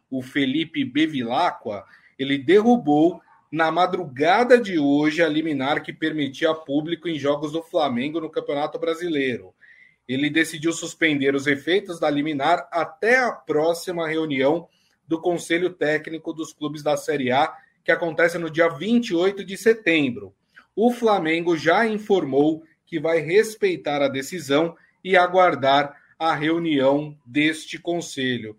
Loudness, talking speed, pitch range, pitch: -22 LUFS, 130 wpm, 150-185 Hz, 165 Hz